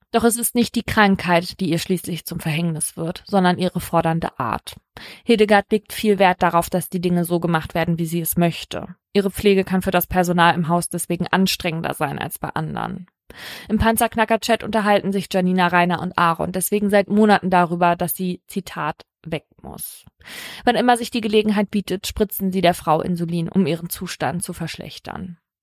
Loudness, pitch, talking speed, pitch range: -20 LUFS, 180 Hz, 185 wpm, 170-205 Hz